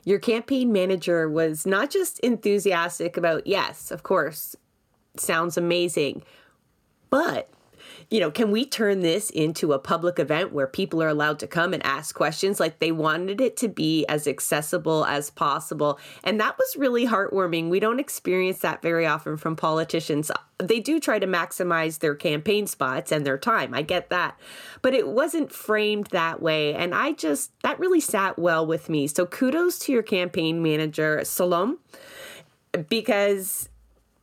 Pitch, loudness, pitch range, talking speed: 180 Hz, -24 LUFS, 160-215 Hz, 165 wpm